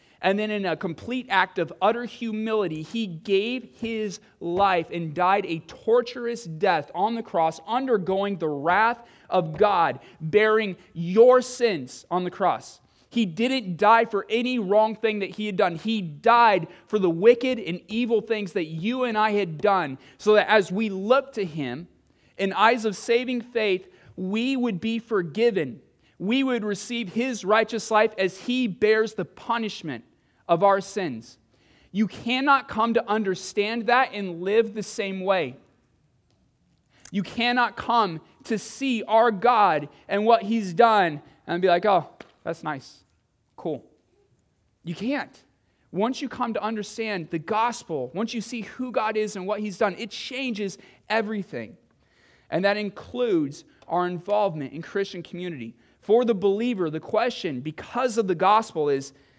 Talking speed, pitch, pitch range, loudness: 160 wpm, 210 Hz, 180-230 Hz, -24 LUFS